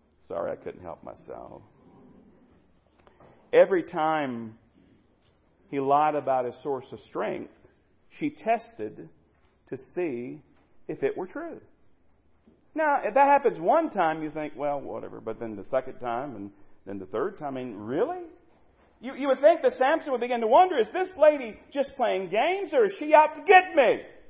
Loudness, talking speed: -25 LUFS, 170 wpm